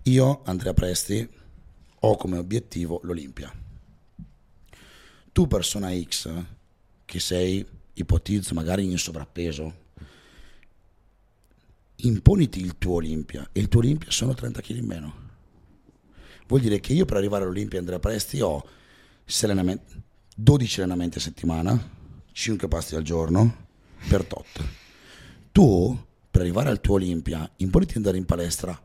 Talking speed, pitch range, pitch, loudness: 125 wpm, 85-110 Hz, 95 Hz, -24 LUFS